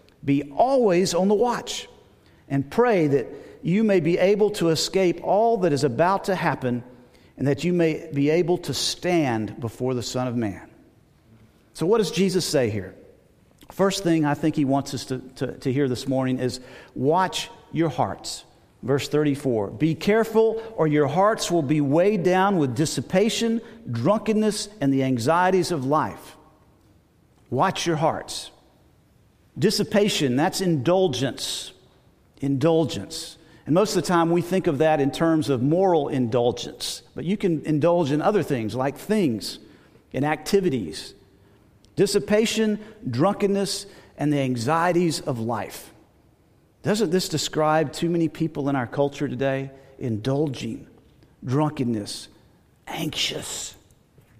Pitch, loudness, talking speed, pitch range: 155 Hz, -23 LUFS, 140 wpm, 135-185 Hz